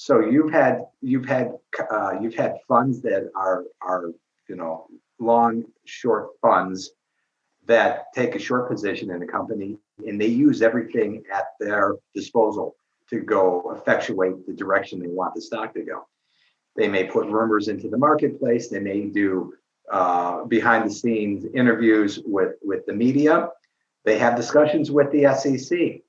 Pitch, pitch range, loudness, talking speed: 115 Hz, 100-130 Hz, -22 LUFS, 155 wpm